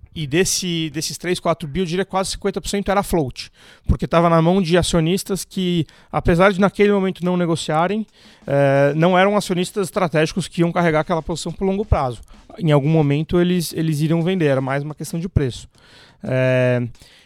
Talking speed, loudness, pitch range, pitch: 175 wpm, -19 LUFS, 155-185 Hz, 170 Hz